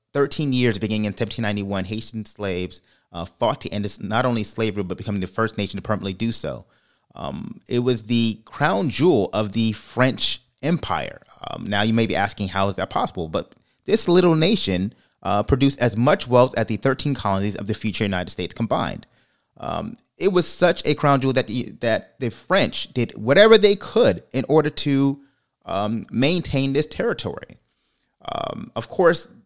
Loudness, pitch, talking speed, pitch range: -21 LUFS, 115 Hz, 180 wpm, 105-140 Hz